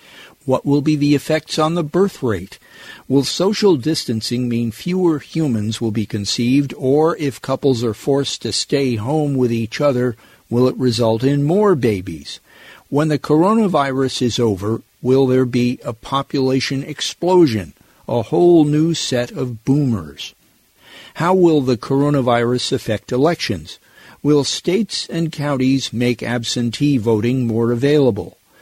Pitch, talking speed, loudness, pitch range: 135 Hz, 140 wpm, -17 LUFS, 120-150 Hz